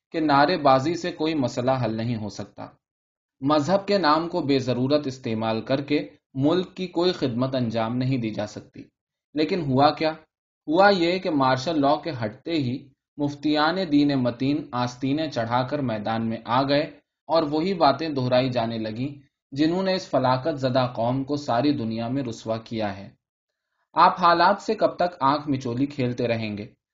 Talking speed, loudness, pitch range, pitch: 175 wpm, -24 LUFS, 120-155 Hz, 140 Hz